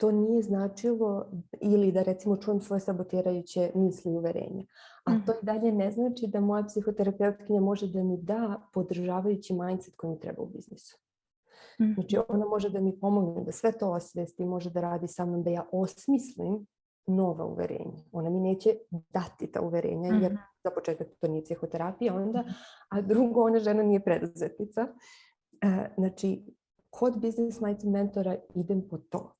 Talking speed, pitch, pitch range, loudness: 160 wpm, 195 Hz, 180-215 Hz, -30 LUFS